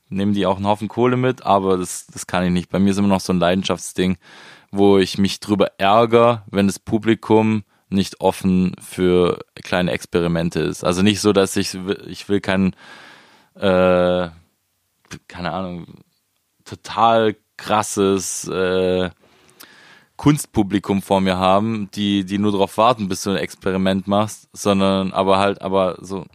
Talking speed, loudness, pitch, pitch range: 155 wpm, -19 LUFS, 95 Hz, 95-105 Hz